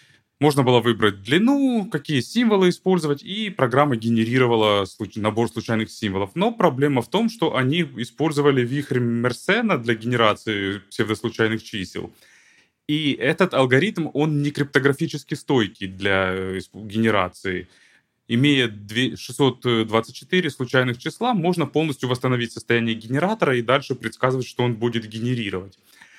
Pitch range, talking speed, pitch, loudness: 110-145 Hz, 115 wpm, 125 Hz, -21 LUFS